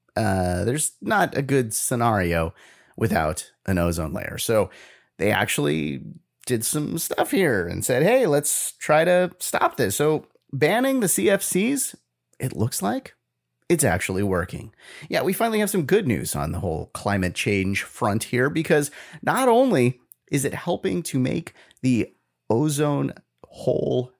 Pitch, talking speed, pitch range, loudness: 130 Hz, 150 wpm, 100-155 Hz, -23 LUFS